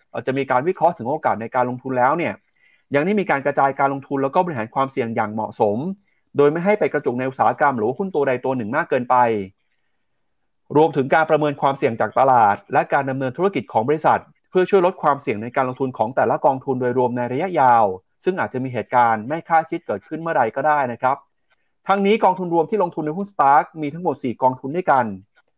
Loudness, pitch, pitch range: -20 LUFS, 140 Hz, 130-165 Hz